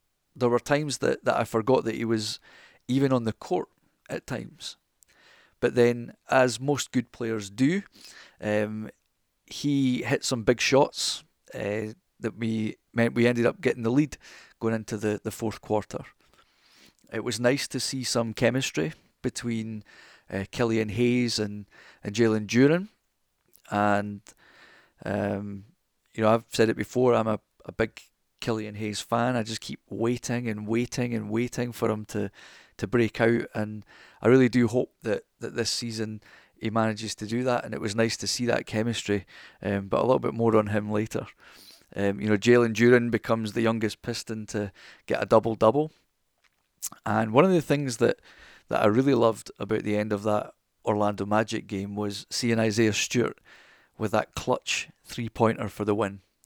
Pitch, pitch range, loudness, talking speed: 115 Hz, 105-120 Hz, -27 LUFS, 175 wpm